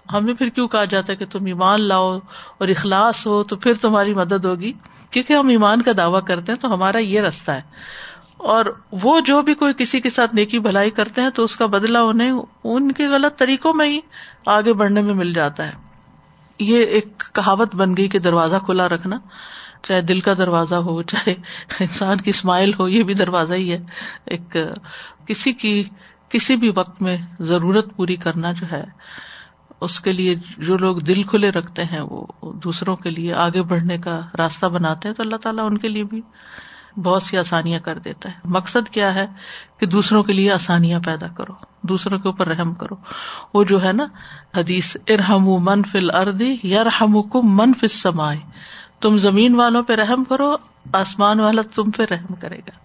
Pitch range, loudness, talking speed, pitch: 180-225 Hz, -18 LUFS, 190 wpm, 200 Hz